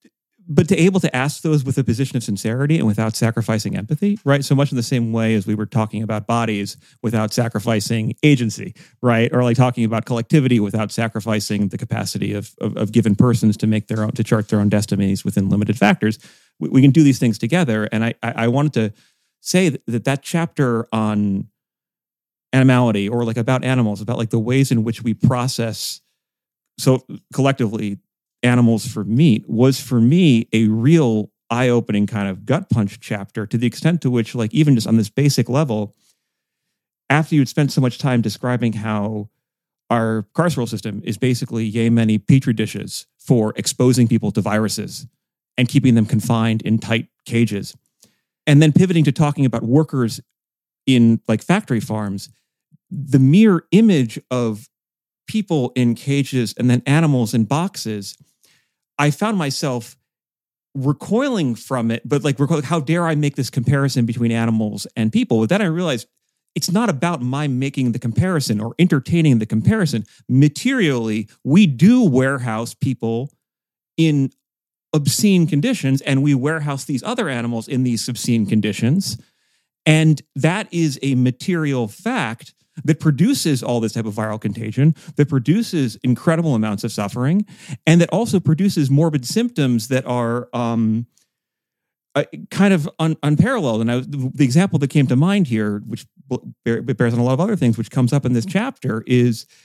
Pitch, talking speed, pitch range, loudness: 125 Hz, 170 wpm, 115-150 Hz, -18 LUFS